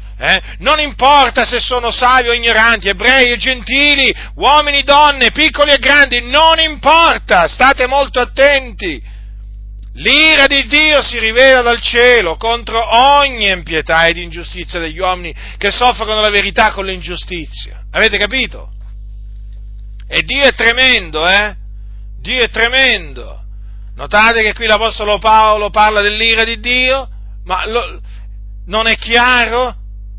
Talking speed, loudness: 130 wpm, -10 LUFS